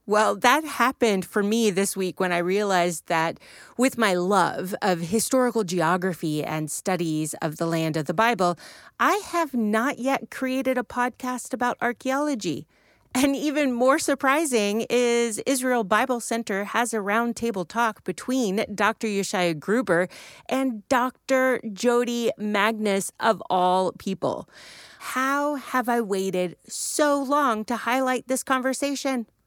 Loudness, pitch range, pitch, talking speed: -24 LUFS, 190-255 Hz, 230 Hz, 135 wpm